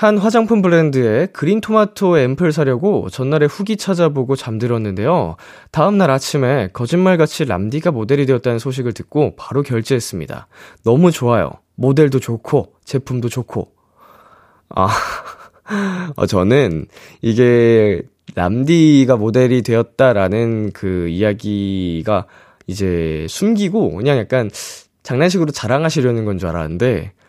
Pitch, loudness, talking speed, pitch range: 130 Hz, -16 LUFS, 285 characters per minute, 110-160 Hz